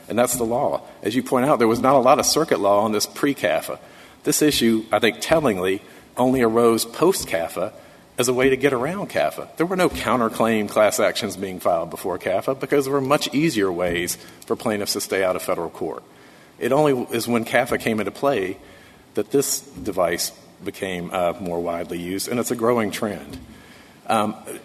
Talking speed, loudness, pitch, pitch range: 200 wpm, -21 LUFS, 115 Hz, 100-130 Hz